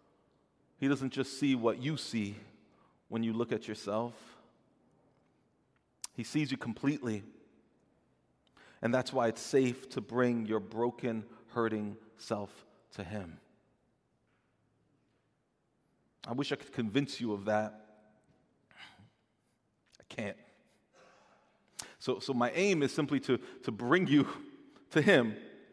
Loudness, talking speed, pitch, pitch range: -34 LUFS, 120 wpm, 115 Hz, 110-135 Hz